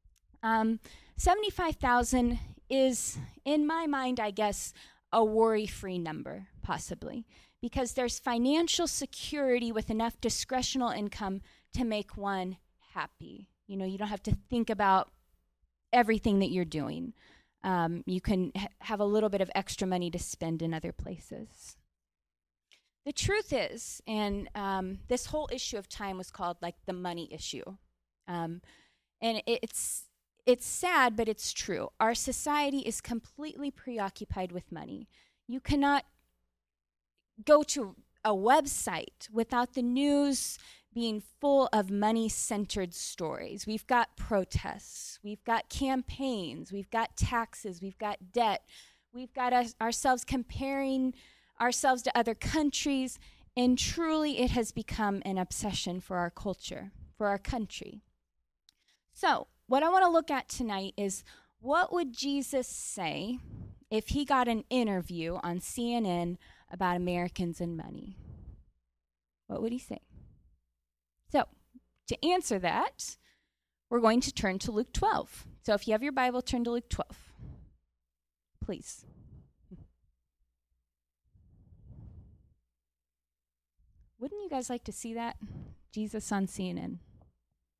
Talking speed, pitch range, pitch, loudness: 130 wpm, 175-250 Hz, 215 Hz, -32 LUFS